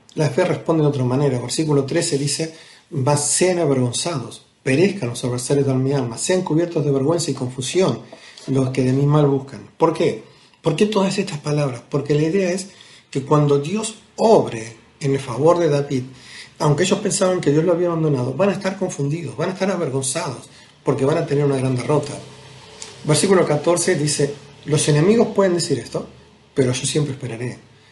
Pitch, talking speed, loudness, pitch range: 145 Hz, 180 wpm, -19 LUFS, 135-170 Hz